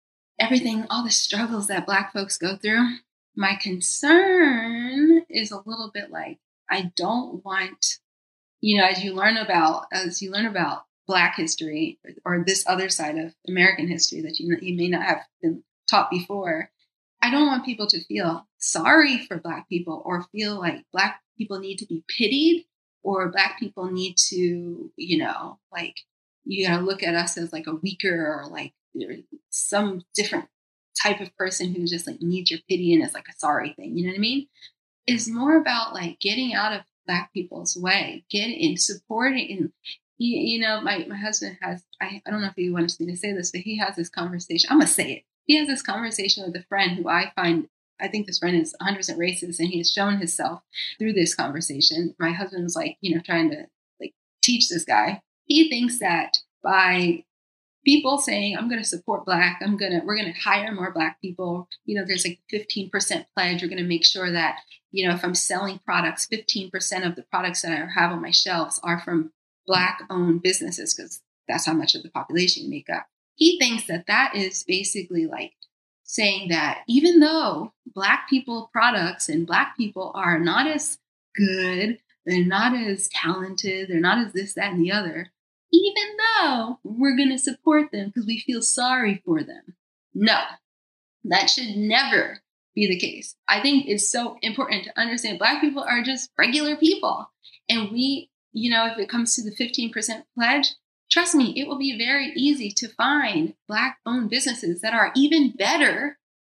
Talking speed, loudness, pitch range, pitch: 195 wpm, -22 LUFS, 180-245 Hz, 200 Hz